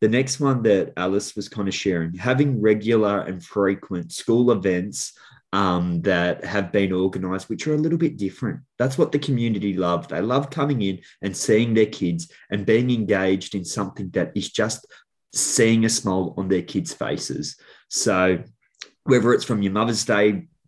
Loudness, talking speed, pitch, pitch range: -22 LUFS, 175 wpm, 100 Hz, 95-115 Hz